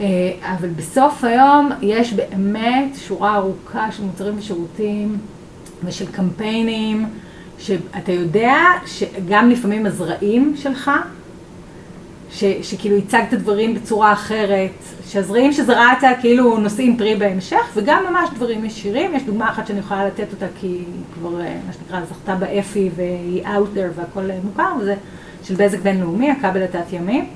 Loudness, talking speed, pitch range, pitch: -18 LUFS, 130 wpm, 190-230 Hz, 205 Hz